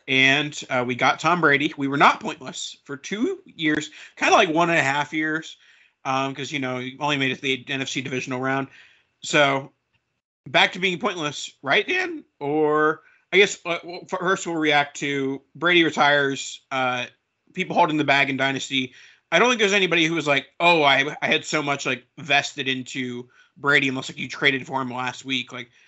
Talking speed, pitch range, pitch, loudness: 195 wpm, 135-160 Hz, 145 Hz, -21 LUFS